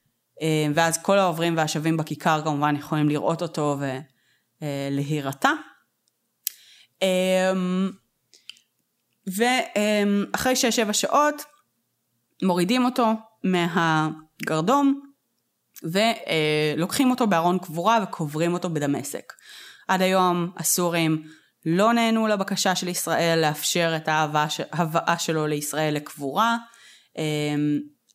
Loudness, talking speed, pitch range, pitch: -23 LUFS, 80 wpm, 155-205 Hz, 170 Hz